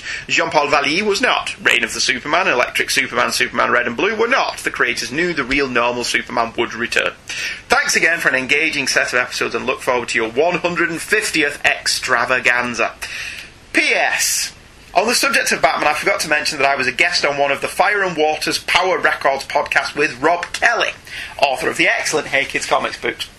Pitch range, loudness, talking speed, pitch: 135-175 Hz, -16 LUFS, 195 wpm, 150 Hz